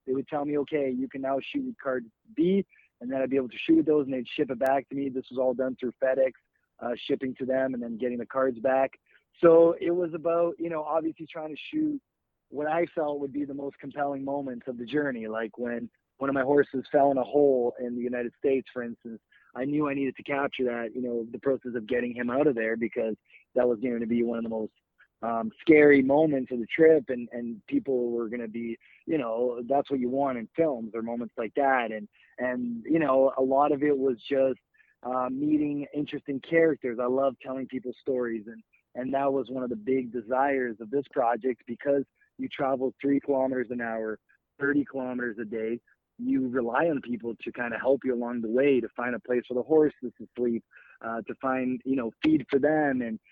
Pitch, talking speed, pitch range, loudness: 130 Hz, 230 wpm, 120-145 Hz, -28 LUFS